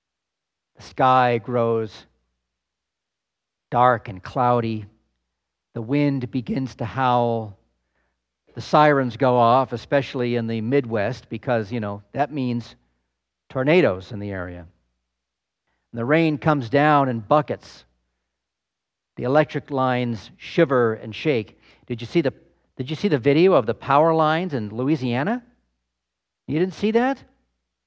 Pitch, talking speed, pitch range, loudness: 120 Hz, 130 wpm, 80-135 Hz, -21 LUFS